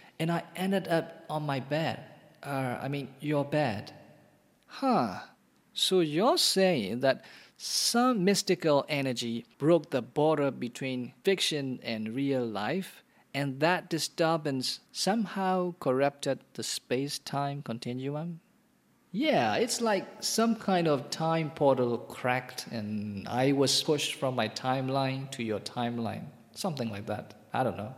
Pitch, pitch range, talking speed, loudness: 145 Hz, 125-175 Hz, 135 wpm, -30 LUFS